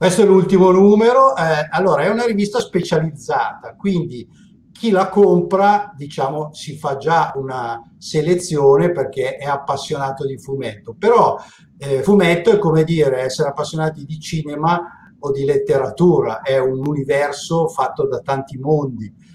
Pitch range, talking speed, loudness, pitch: 140-195 Hz, 140 wpm, -17 LUFS, 160 Hz